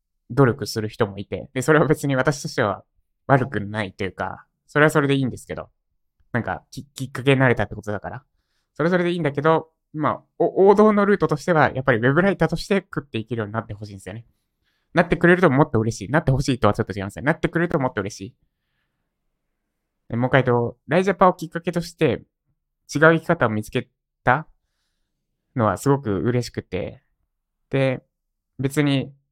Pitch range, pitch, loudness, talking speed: 115-160 Hz, 135 Hz, -21 LUFS, 410 characters per minute